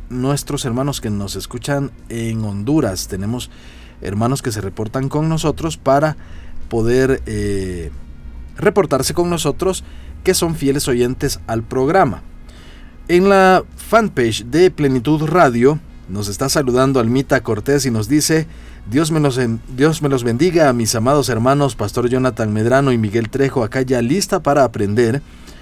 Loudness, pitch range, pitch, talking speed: -17 LUFS, 110-145 Hz, 130 Hz, 145 wpm